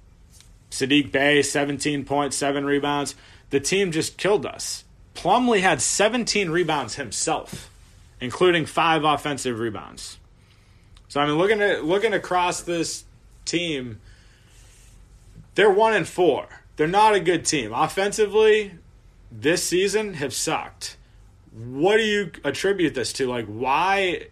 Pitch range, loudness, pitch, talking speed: 115-180 Hz, -22 LUFS, 145 Hz, 125 wpm